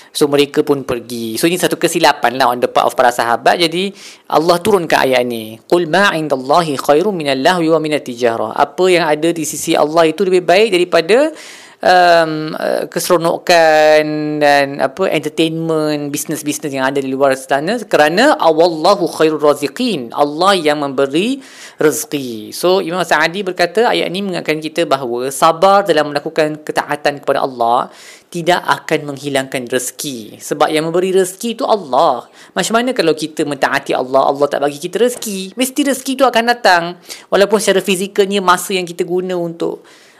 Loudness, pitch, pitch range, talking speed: -14 LUFS, 165 Hz, 145-185 Hz, 160 wpm